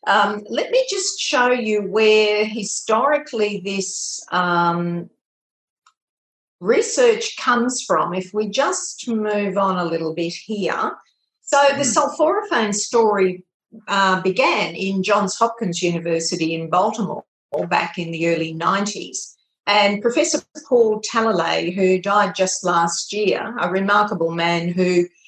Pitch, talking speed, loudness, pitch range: 205 Hz, 125 wpm, -19 LUFS, 180-230 Hz